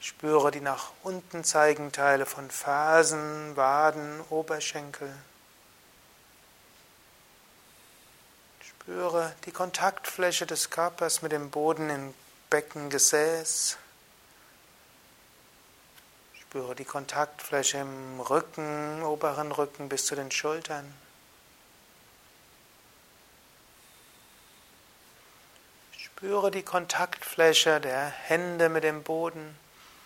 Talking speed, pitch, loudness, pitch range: 80 wpm, 150 Hz, -28 LUFS, 140-160 Hz